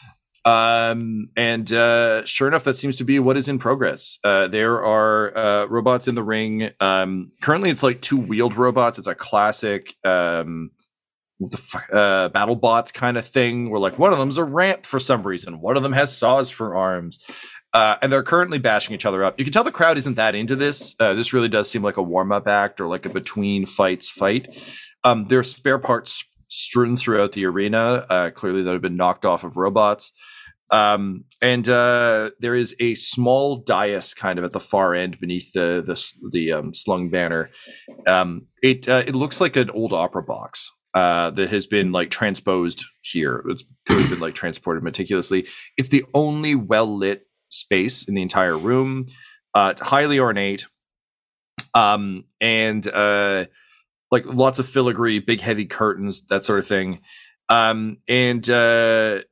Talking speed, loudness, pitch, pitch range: 180 wpm, -20 LUFS, 115 Hz, 100-130 Hz